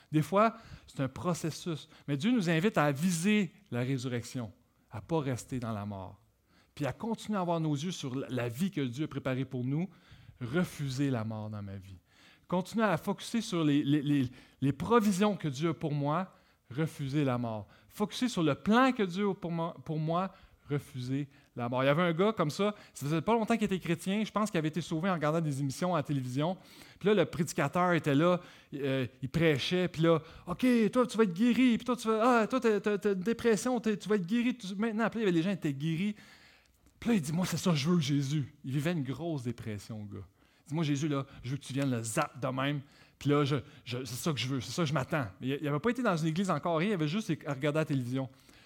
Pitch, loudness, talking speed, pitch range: 155 Hz, -32 LUFS, 240 wpm, 135-190 Hz